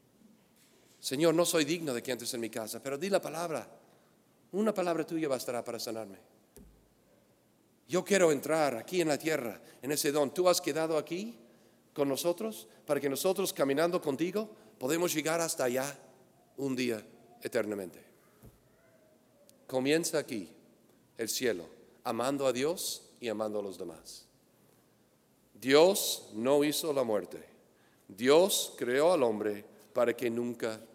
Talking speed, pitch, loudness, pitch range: 140 wpm, 145 Hz, -31 LUFS, 120-165 Hz